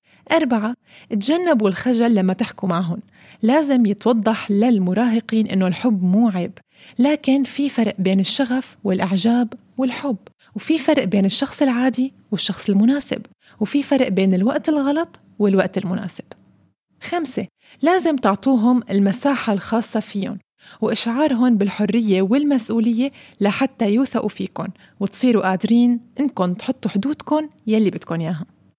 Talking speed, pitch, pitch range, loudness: 115 wpm, 230 Hz, 200-260 Hz, -19 LUFS